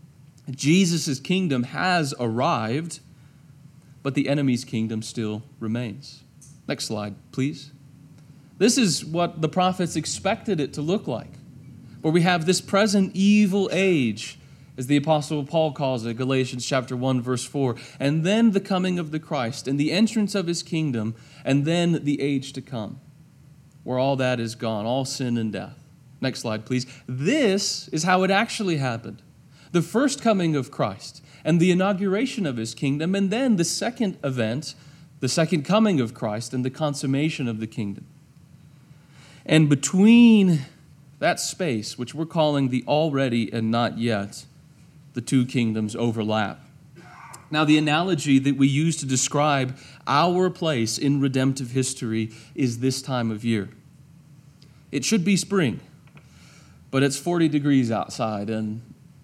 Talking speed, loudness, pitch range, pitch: 150 wpm, -23 LUFS, 130-165 Hz, 145 Hz